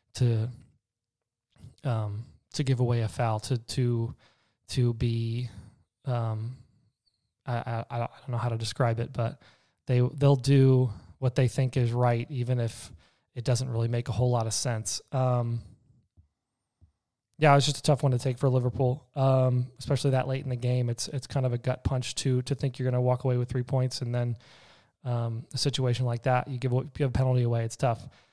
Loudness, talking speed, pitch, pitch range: -28 LUFS, 195 wpm, 125 Hz, 115-130 Hz